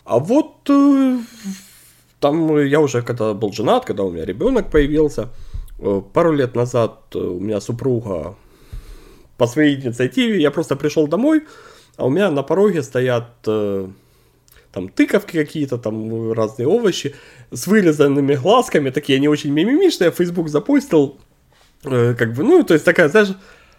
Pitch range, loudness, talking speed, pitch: 120-195 Hz, -17 LUFS, 135 wpm, 145 Hz